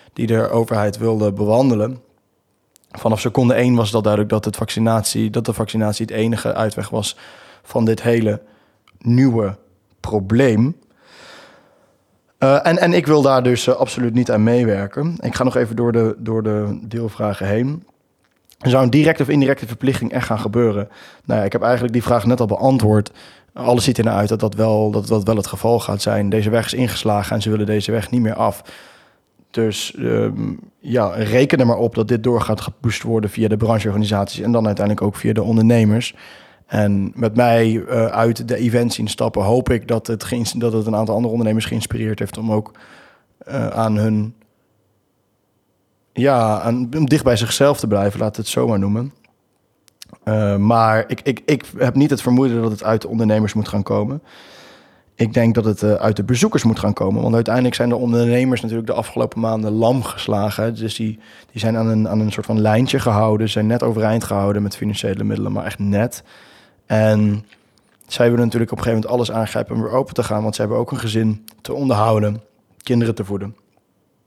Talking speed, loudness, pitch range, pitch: 195 wpm, -18 LUFS, 105-120 Hz, 110 Hz